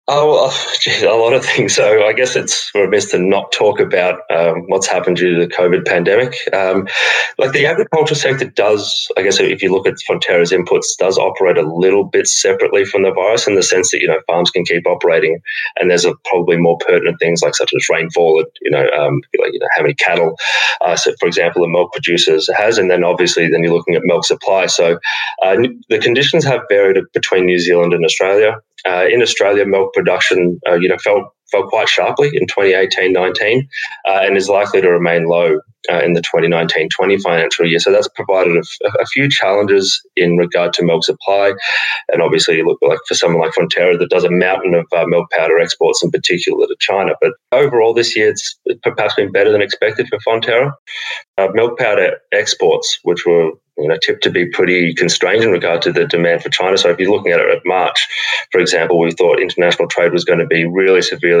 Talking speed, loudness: 215 wpm, -13 LUFS